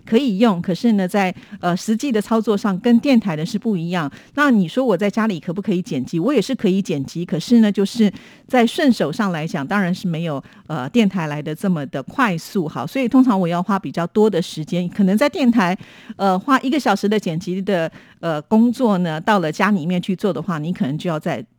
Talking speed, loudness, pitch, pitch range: 320 characters per minute, -19 LUFS, 195 Hz, 175-225 Hz